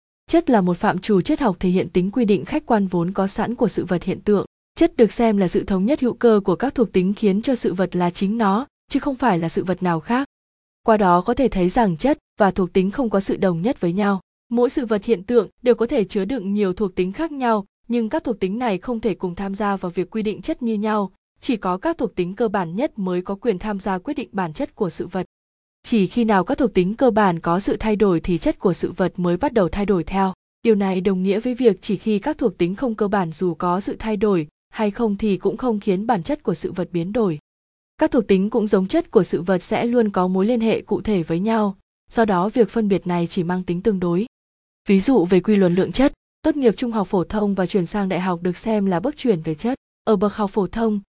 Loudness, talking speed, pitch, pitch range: -20 LUFS, 275 wpm, 205 Hz, 185-235 Hz